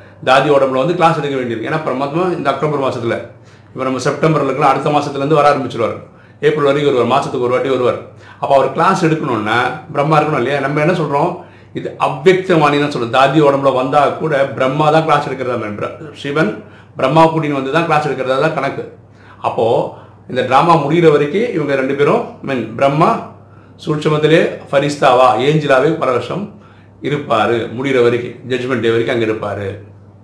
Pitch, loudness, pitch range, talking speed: 140 Hz, -14 LUFS, 125-155 Hz, 155 wpm